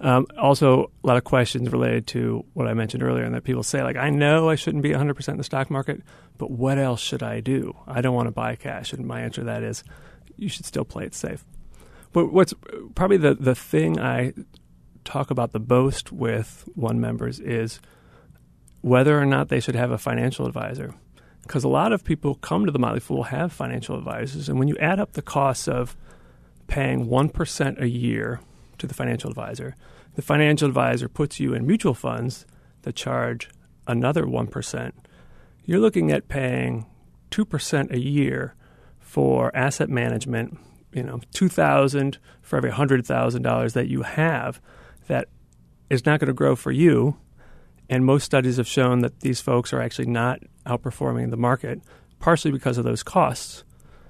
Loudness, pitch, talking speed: -23 LUFS, 125 Hz, 180 wpm